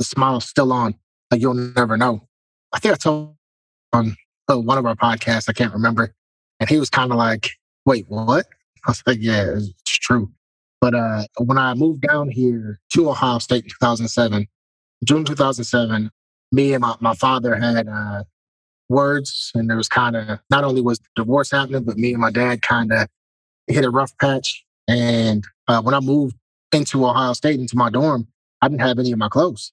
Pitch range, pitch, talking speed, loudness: 110-130 Hz, 120 Hz, 195 wpm, -19 LUFS